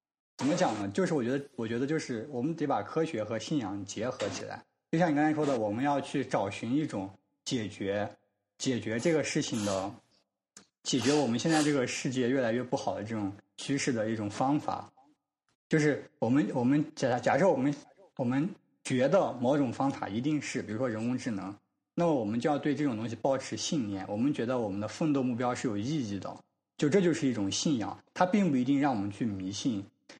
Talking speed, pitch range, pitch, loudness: 310 characters per minute, 105-145 Hz, 130 Hz, -31 LUFS